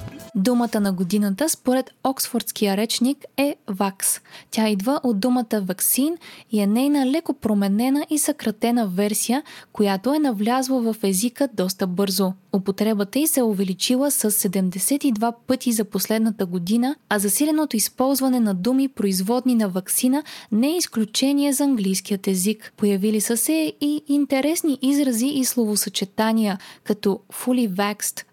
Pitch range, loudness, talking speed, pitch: 205-265 Hz, -21 LUFS, 135 wpm, 230 Hz